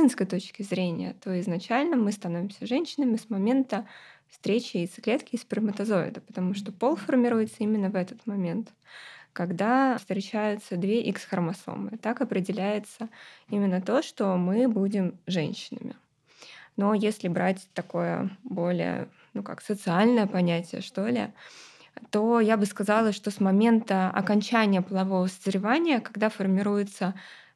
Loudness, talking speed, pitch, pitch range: -27 LUFS, 120 wpm, 205 Hz, 190-230 Hz